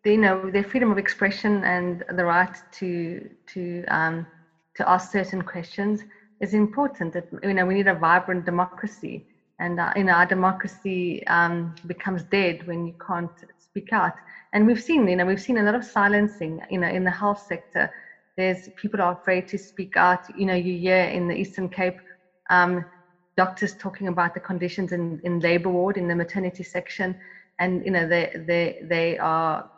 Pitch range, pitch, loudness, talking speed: 175-195 Hz, 180 Hz, -24 LUFS, 190 wpm